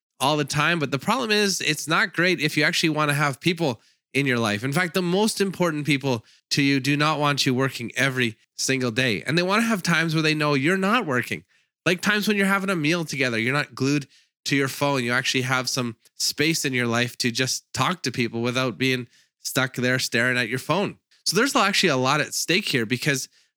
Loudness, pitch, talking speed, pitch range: -22 LUFS, 145 Hz, 235 wpm, 130-175 Hz